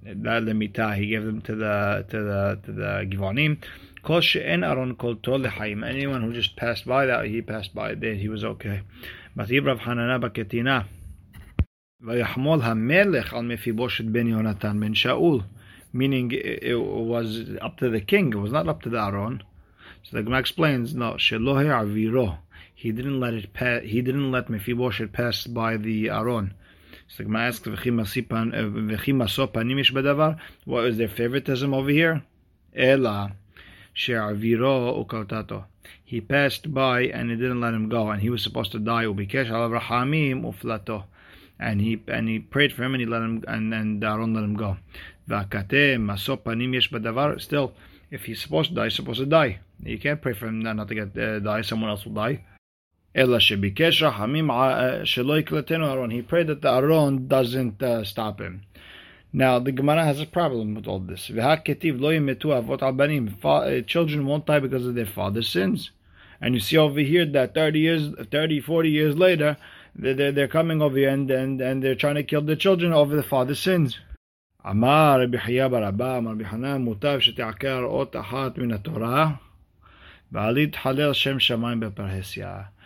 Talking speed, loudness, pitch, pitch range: 145 wpm, -24 LUFS, 120 Hz, 105-135 Hz